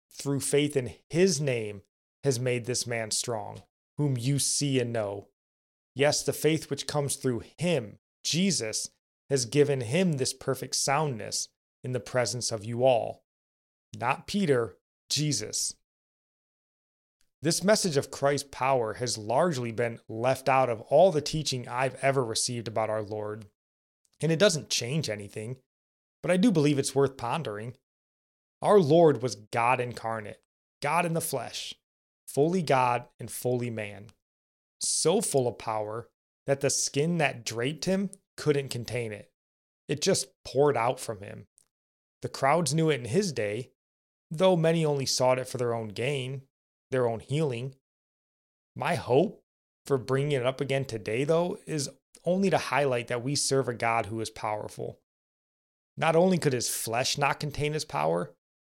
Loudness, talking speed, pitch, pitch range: -28 LUFS, 155 wpm, 130 Hz, 115-145 Hz